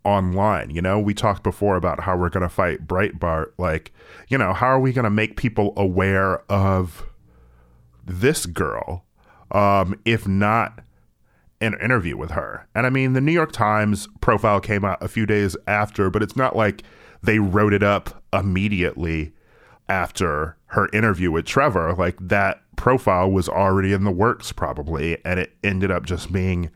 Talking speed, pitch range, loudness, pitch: 175 wpm, 90-105 Hz, -21 LUFS, 100 Hz